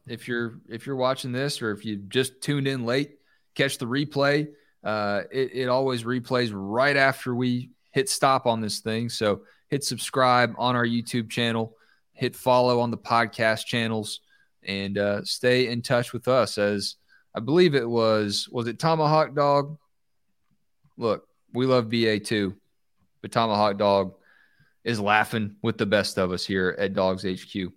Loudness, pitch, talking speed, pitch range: -25 LUFS, 120 Hz, 165 wpm, 105-130 Hz